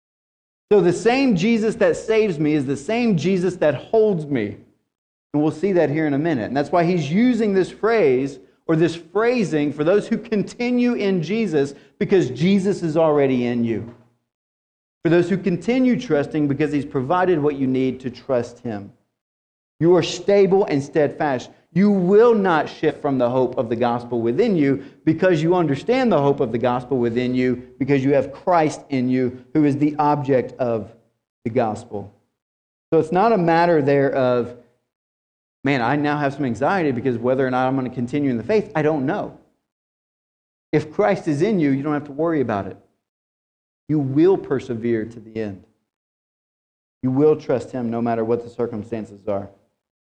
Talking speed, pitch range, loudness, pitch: 185 wpm, 120-180 Hz, -20 LUFS, 145 Hz